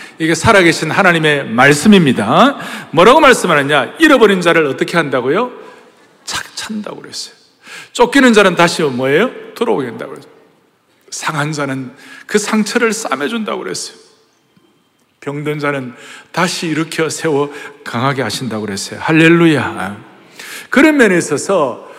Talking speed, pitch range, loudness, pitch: 310 characters per minute, 145-220 Hz, -12 LUFS, 165 Hz